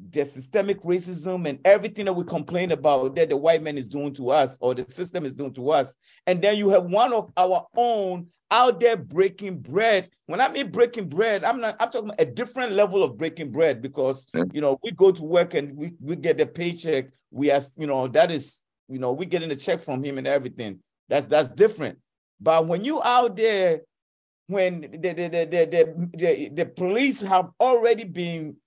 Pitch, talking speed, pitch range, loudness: 175 Hz, 210 wpm, 145-205 Hz, -23 LUFS